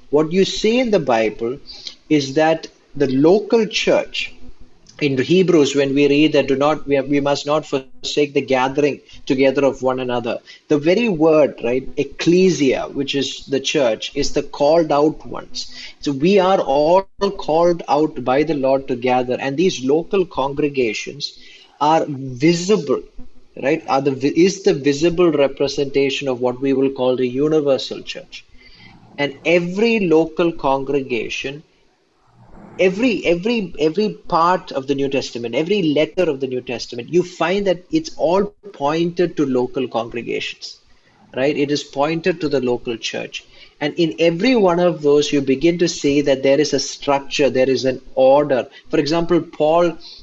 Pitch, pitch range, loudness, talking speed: 145 Hz, 135-175 Hz, -18 LUFS, 160 wpm